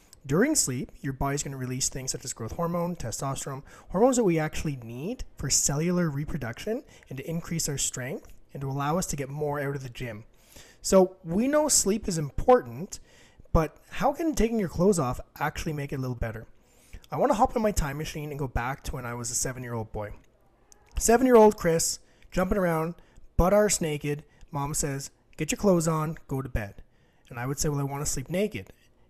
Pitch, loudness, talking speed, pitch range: 150 Hz, -27 LUFS, 215 wpm, 130-175 Hz